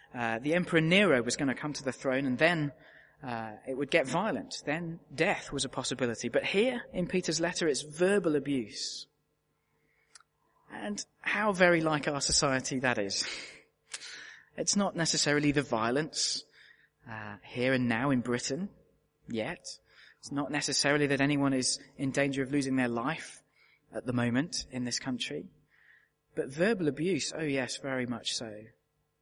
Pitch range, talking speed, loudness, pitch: 125-160 Hz, 160 wpm, -30 LUFS, 140 Hz